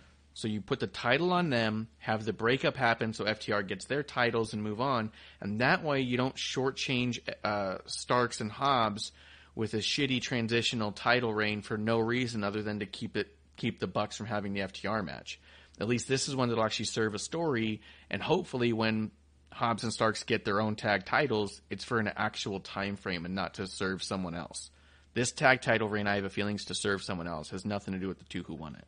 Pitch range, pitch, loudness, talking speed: 95-120 Hz, 110 Hz, -32 LUFS, 225 wpm